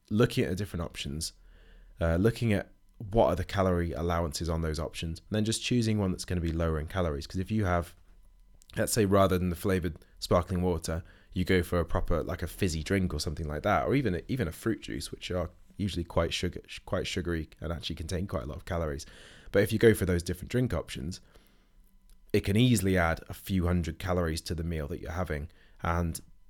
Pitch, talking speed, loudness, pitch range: 90 Hz, 220 wpm, -30 LUFS, 85-95 Hz